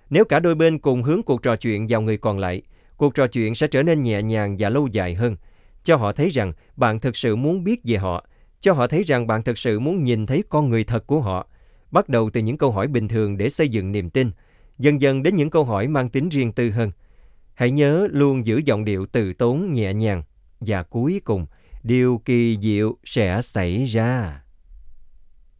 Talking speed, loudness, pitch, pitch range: 220 wpm, -21 LUFS, 115 Hz, 105-135 Hz